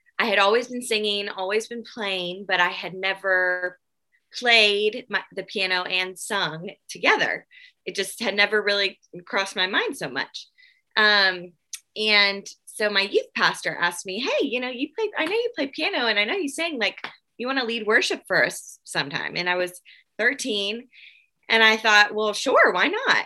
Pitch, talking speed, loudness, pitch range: 205 Hz, 180 wpm, -22 LUFS, 190-235 Hz